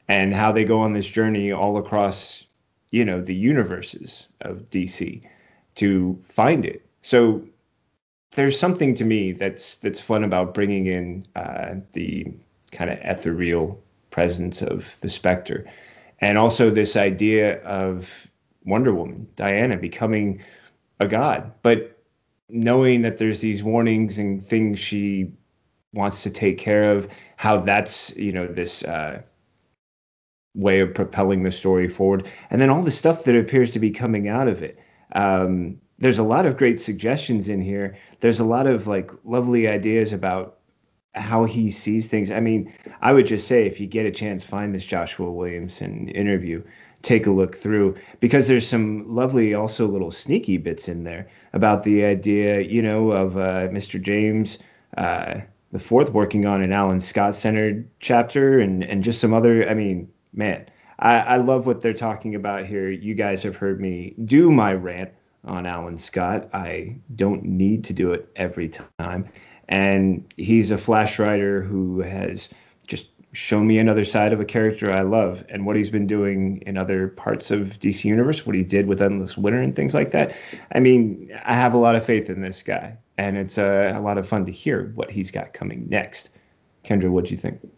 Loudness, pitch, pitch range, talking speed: -21 LUFS, 100 Hz, 95-110 Hz, 180 wpm